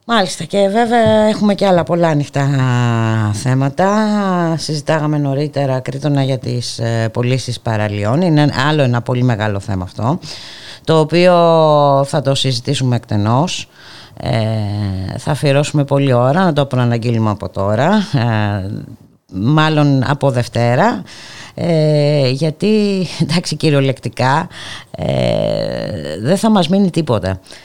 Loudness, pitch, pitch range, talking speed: -15 LUFS, 140 Hz, 120-165 Hz, 115 wpm